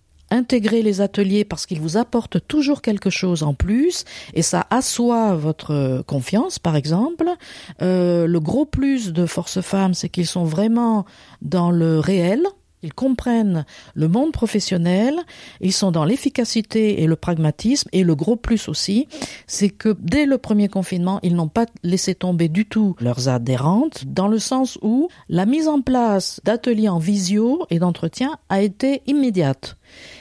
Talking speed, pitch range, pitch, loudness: 160 wpm, 175-240 Hz, 200 Hz, -19 LUFS